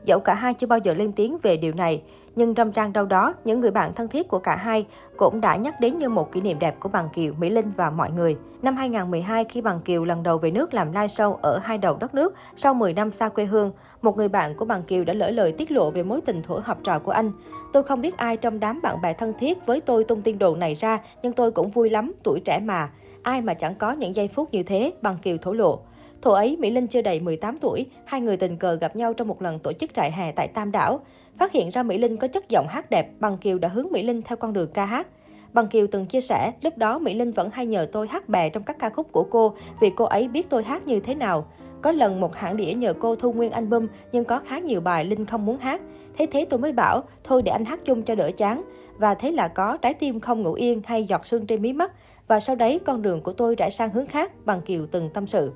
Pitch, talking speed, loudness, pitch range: 225 Hz, 280 wpm, -23 LUFS, 195-250 Hz